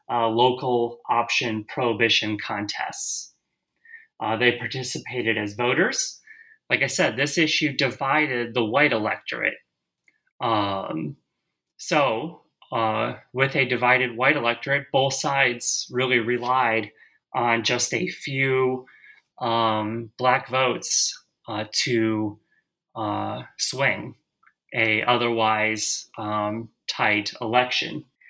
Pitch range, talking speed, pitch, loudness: 115-130 Hz, 100 wpm, 120 Hz, -23 LUFS